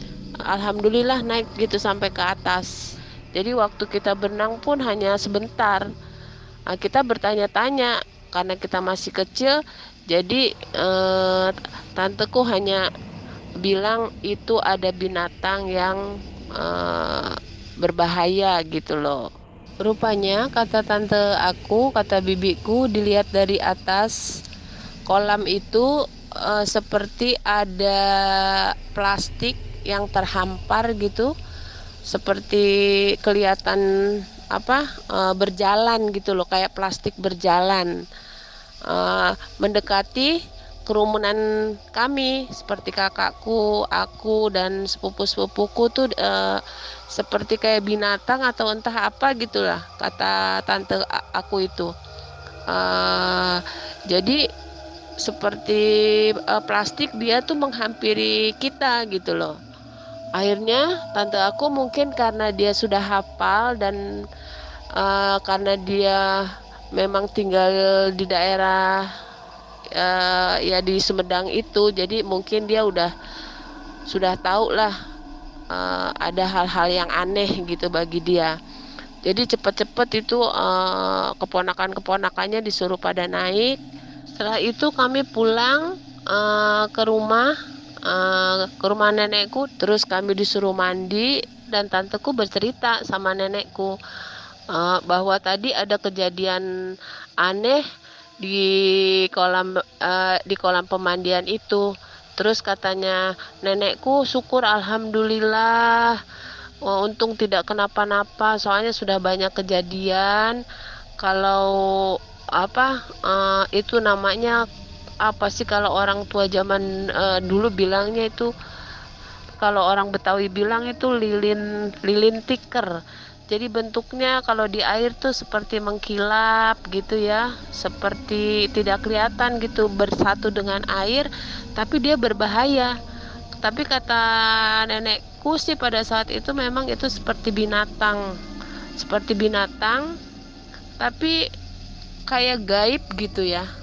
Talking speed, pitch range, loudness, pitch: 105 wpm, 190-225 Hz, -21 LUFS, 205 Hz